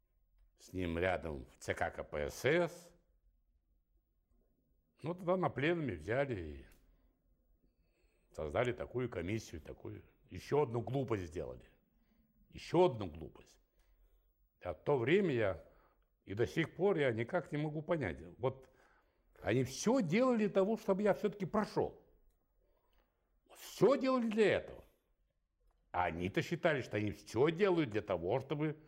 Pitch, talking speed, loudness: 130 Hz, 125 wpm, -36 LUFS